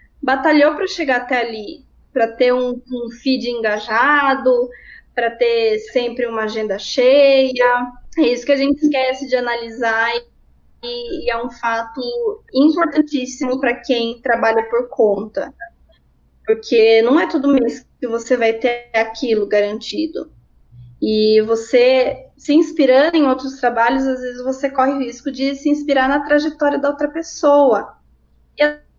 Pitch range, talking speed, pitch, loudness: 235-285 Hz, 145 wpm, 255 Hz, -17 LUFS